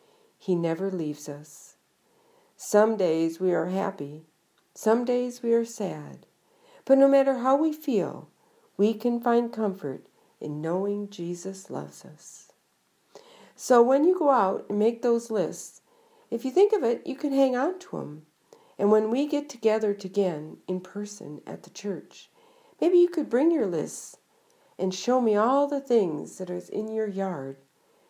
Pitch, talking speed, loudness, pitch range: 225 Hz, 165 wpm, -26 LUFS, 190-285 Hz